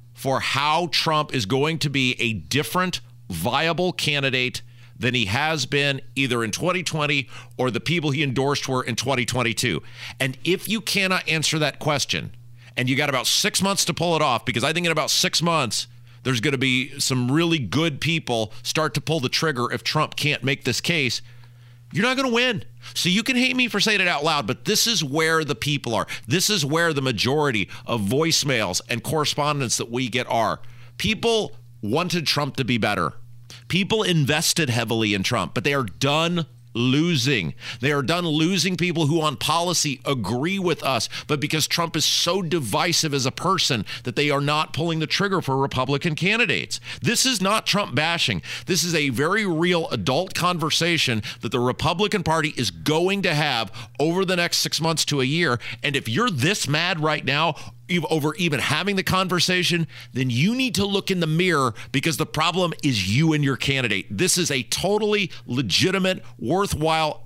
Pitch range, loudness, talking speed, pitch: 125-170 Hz, -22 LUFS, 190 wpm, 145 Hz